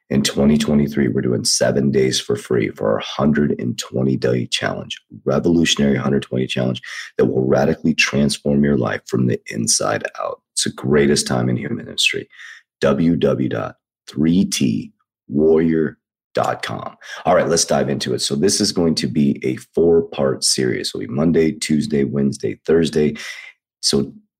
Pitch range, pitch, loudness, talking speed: 65-75 Hz, 70 Hz, -18 LUFS, 140 wpm